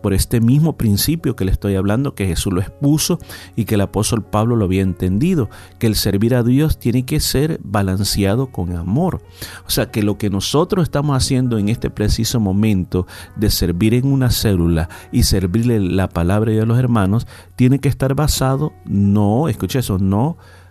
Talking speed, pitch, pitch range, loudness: 190 wpm, 110 Hz, 95-130 Hz, -17 LUFS